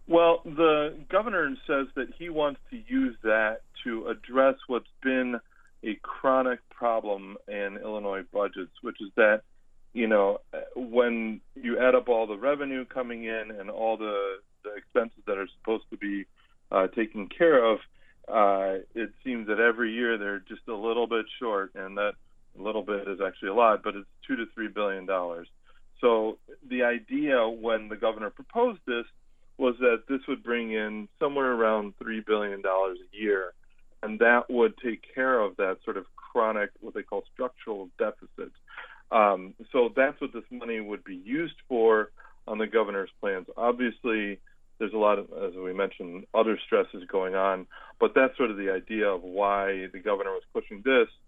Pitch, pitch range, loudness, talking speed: 115 Hz, 100-130 Hz, -28 LUFS, 170 wpm